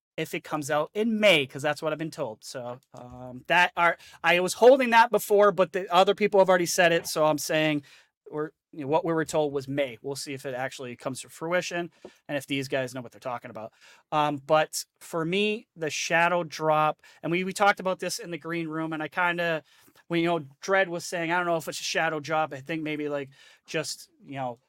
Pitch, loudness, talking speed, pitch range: 160 Hz, -26 LUFS, 240 wpm, 145-180 Hz